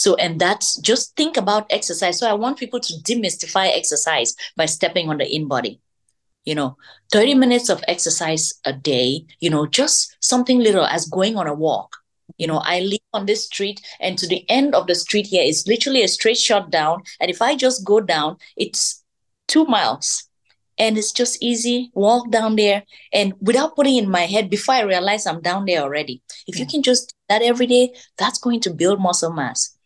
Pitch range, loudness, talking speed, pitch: 165-240 Hz, -18 LUFS, 205 wpm, 205 Hz